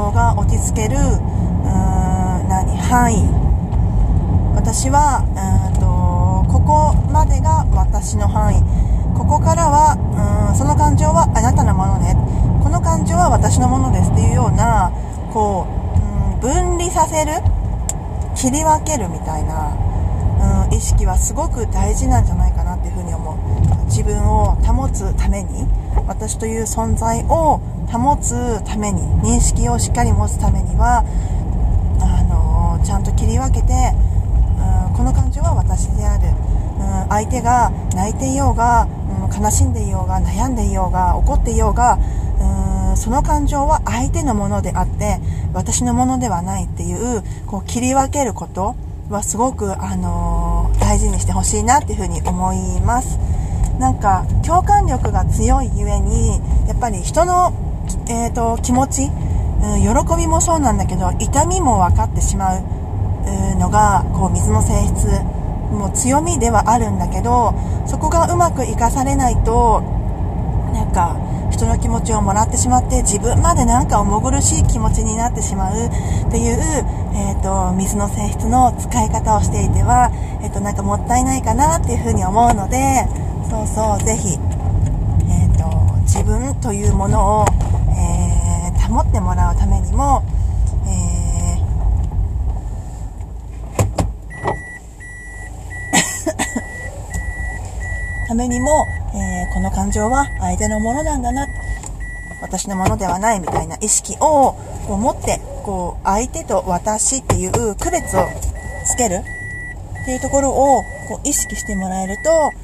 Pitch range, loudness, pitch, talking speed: 90-100 Hz, -17 LUFS, 95 Hz, 280 characters per minute